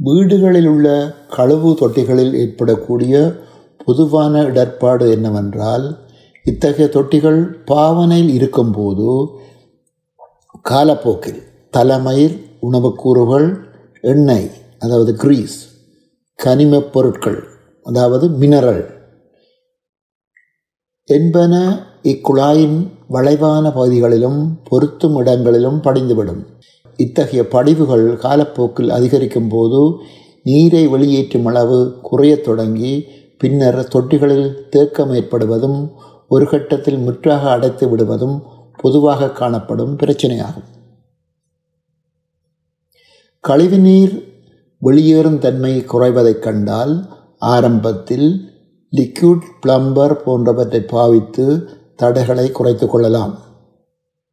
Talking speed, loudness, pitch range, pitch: 70 wpm, -13 LUFS, 125-155 Hz, 135 Hz